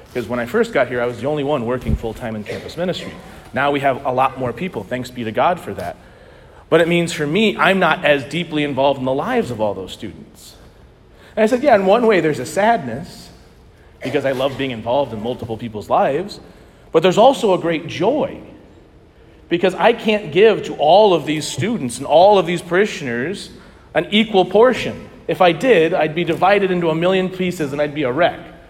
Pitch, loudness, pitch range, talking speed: 150 Hz, -17 LUFS, 125-185 Hz, 215 wpm